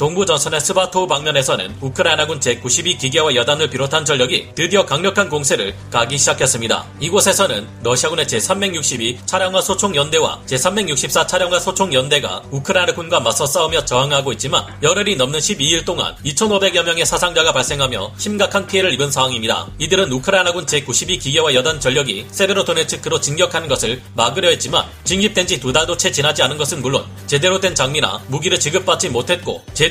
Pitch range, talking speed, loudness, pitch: 140-185 Hz, 410 characters per minute, -16 LUFS, 165 Hz